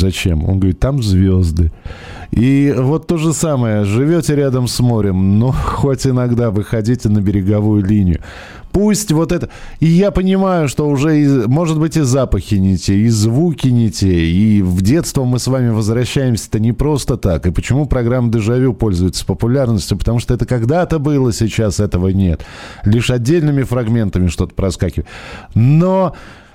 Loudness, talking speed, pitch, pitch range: -14 LUFS, 155 wpm, 120 Hz, 100-140 Hz